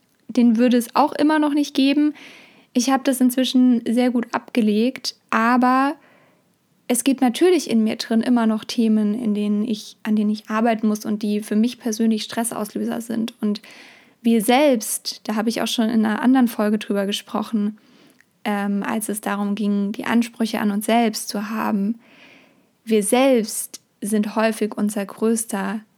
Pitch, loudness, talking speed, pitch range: 230 Hz, -20 LUFS, 165 wpm, 215-250 Hz